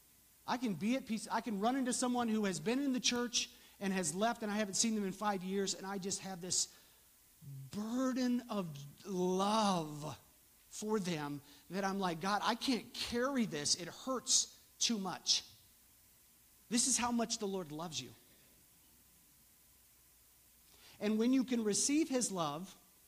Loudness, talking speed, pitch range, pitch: -36 LUFS, 165 wpm, 175-240 Hz, 205 Hz